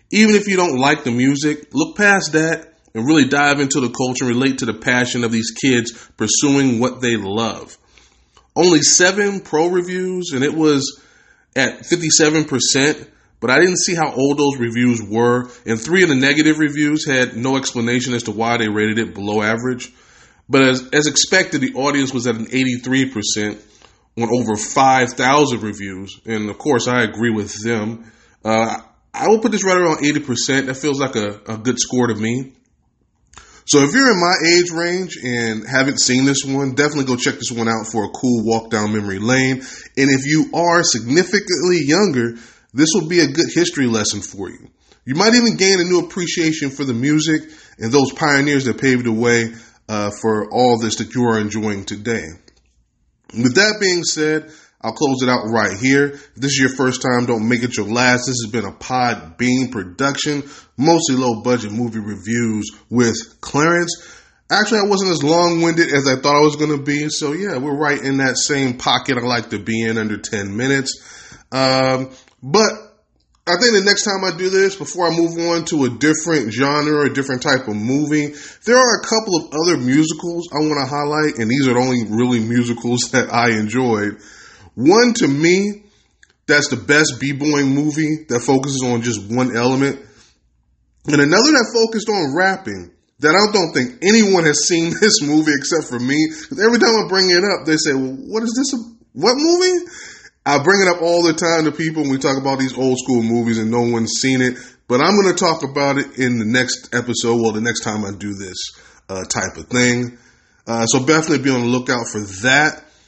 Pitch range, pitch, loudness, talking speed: 120-155 Hz, 135 Hz, -16 LUFS, 200 wpm